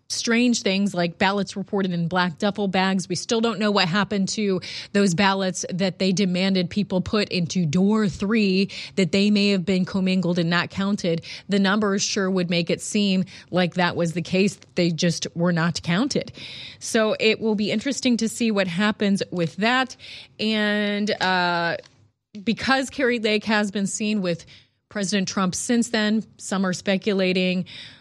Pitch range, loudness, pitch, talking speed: 180-210 Hz, -22 LUFS, 195 Hz, 170 wpm